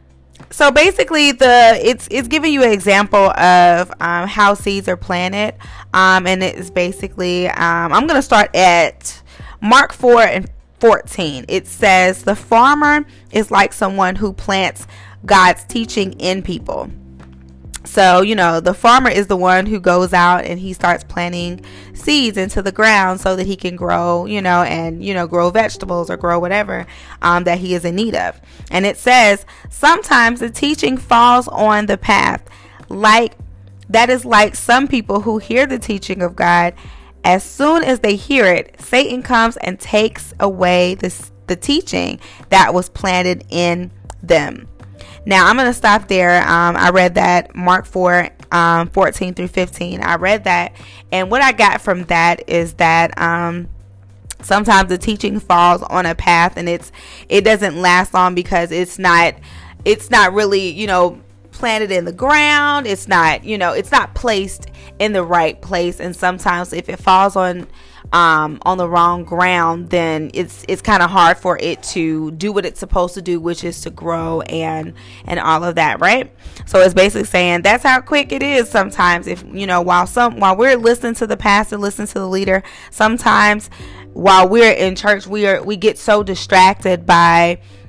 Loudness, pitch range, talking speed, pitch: -13 LUFS, 175-210 Hz, 180 wpm, 185 Hz